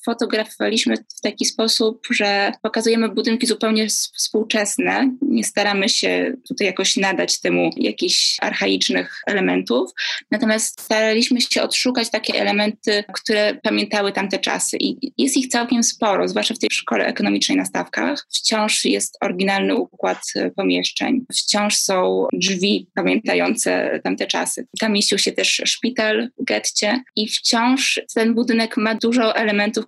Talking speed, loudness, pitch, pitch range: 135 wpm, -19 LUFS, 220 Hz, 205-235 Hz